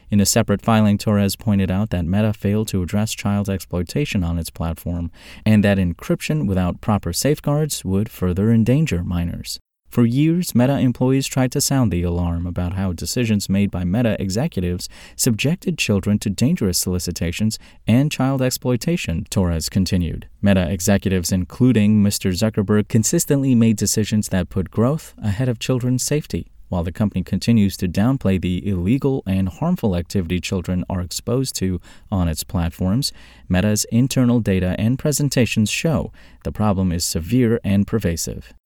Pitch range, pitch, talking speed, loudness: 90-120 Hz, 100 Hz, 150 wpm, -20 LUFS